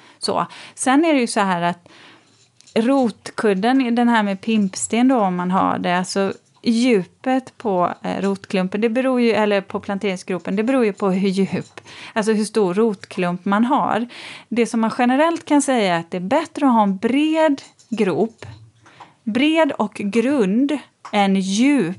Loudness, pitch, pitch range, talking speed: -19 LUFS, 215 Hz, 195-250 Hz, 165 wpm